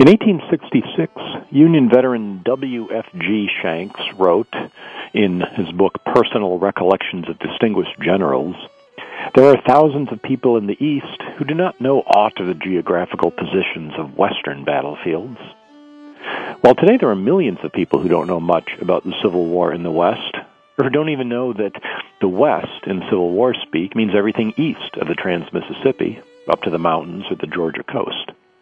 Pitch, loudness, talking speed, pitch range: 130 Hz, -18 LUFS, 170 wpm, 105-155 Hz